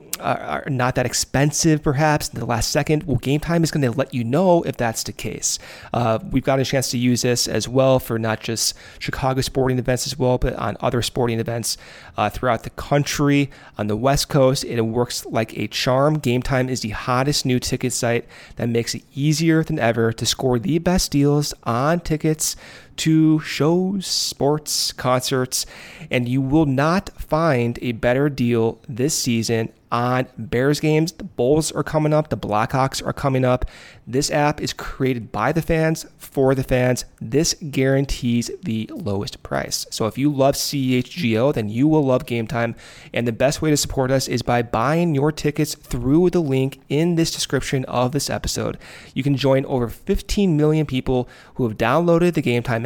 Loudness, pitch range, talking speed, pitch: -20 LUFS, 120-150 Hz, 190 wpm, 130 Hz